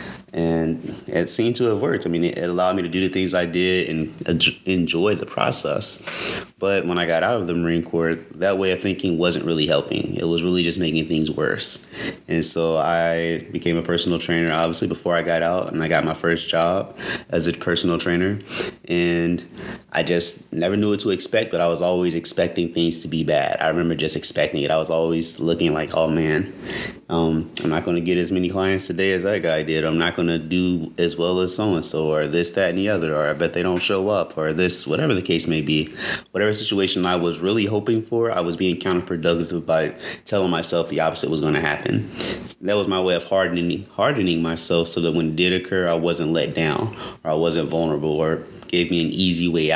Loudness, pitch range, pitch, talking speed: -21 LUFS, 80-90 Hz, 85 Hz, 225 wpm